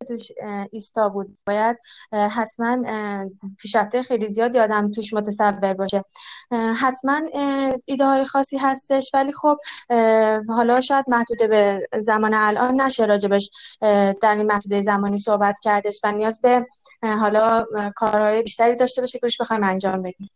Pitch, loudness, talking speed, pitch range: 220 Hz, -20 LUFS, 135 wpm, 205-250 Hz